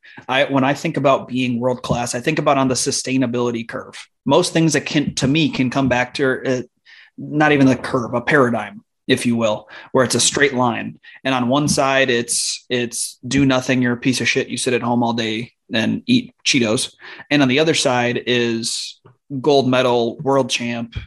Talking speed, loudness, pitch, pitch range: 200 wpm, -18 LUFS, 130 Hz, 120-140 Hz